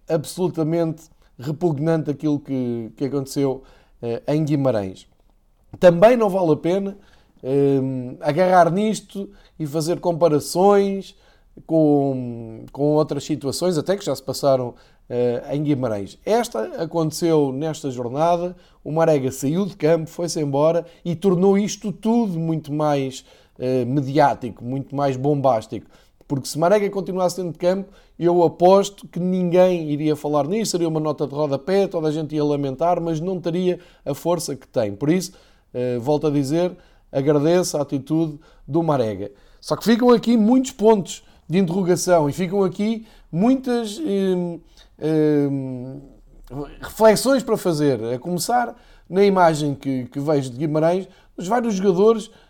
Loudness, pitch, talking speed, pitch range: -20 LUFS, 160 Hz, 145 wpm, 140-185 Hz